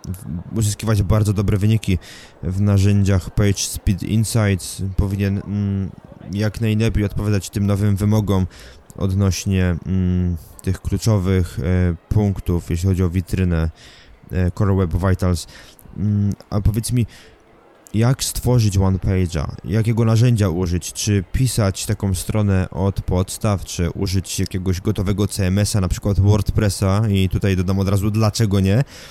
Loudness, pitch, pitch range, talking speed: -19 LUFS, 100 Hz, 95-105 Hz, 130 wpm